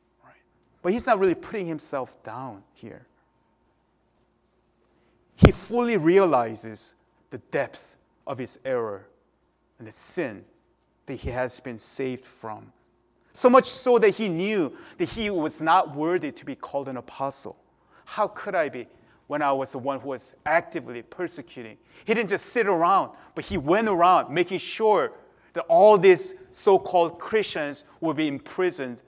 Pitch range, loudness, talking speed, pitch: 135-220 Hz, -24 LUFS, 150 wpm, 165 Hz